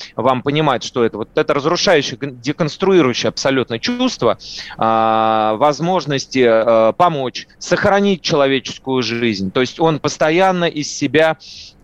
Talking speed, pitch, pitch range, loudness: 115 wpm, 135 Hz, 115-165 Hz, -16 LUFS